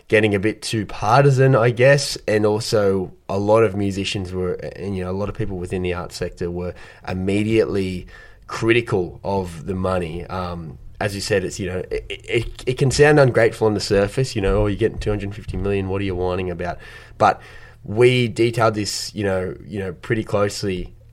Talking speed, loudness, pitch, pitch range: 195 wpm, -20 LUFS, 100 Hz, 95-115 Hz